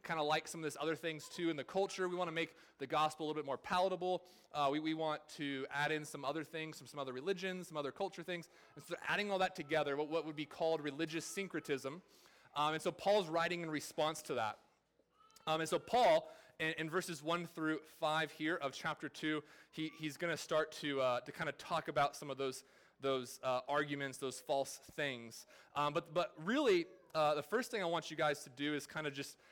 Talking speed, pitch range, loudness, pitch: 235 wpm, 145-170 Hz, -39 LUFS, 155 Hz